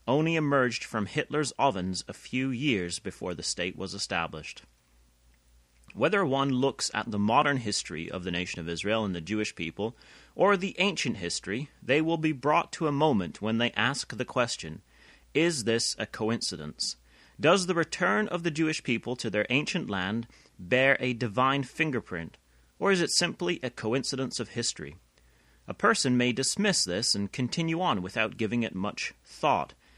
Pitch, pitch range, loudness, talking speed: 120 Hz, 95-145 Hz, -28 LUFS, 170 wpm